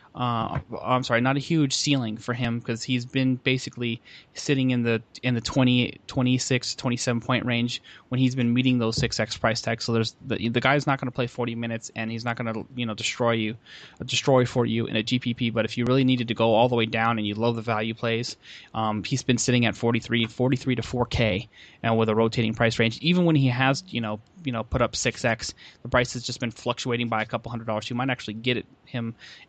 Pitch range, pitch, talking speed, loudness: 115-125 Hz, 120 Hz, 240 wpm, -25 LUFS